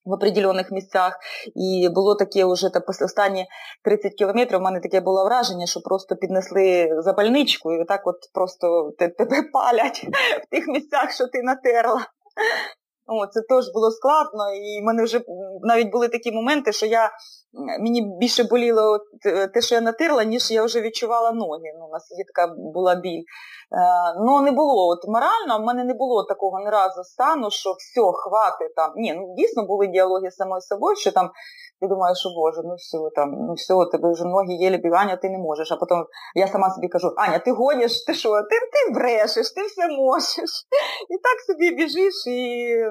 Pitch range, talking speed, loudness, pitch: 185-245 Hz, 185 wpm, -21 LUFS, 210 Hz